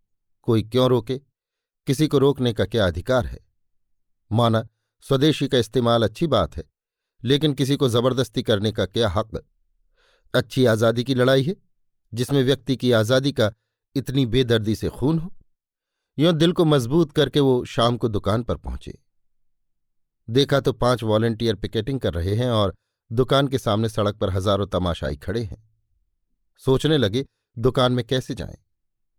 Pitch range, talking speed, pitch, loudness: 105-135 Hz, 155 wpm, 120 Hz, -21 LUFS